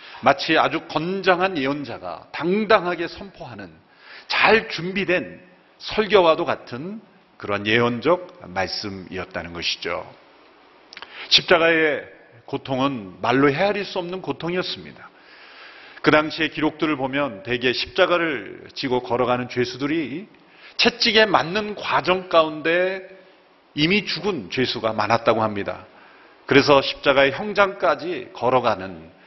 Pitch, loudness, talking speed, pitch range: 155 Hz, -21 LUFS, 265 characters per minute, 125-185 Hz